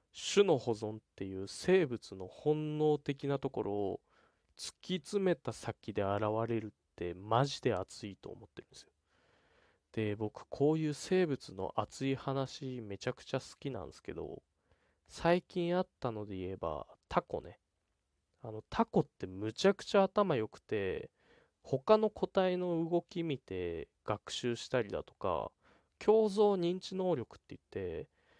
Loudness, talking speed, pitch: -35 LUFS, 270 characters per minute, 130 Hz